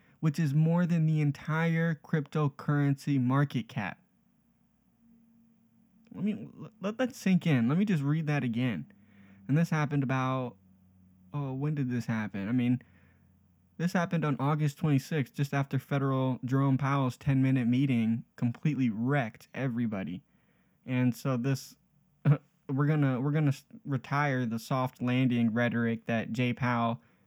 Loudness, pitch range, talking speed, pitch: -30 LUFS, 125-155 Hz, 140 wpm, 140 Hz